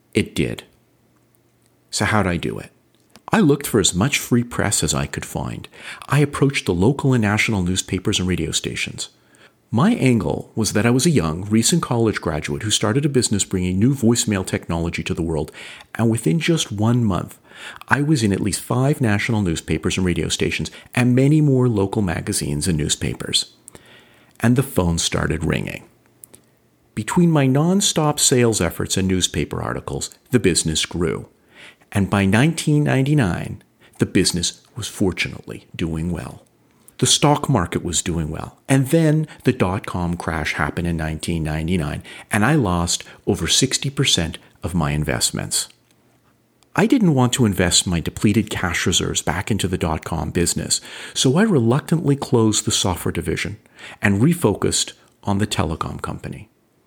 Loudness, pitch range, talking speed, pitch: -19 LUFS, 85-130 Hz, 155 wpm, 105 Hz